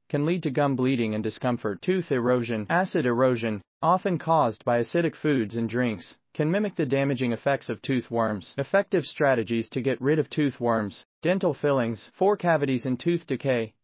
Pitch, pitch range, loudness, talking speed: 135 Hz, 120-160 Hz, -26 LUFS, 180 wpm